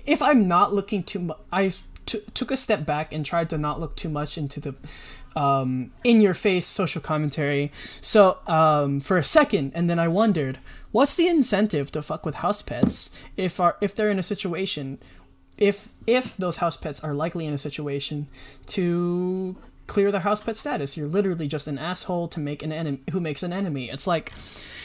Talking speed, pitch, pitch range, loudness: 200 wpm, 170 Hz, 150-200 Hz, -23 LUFS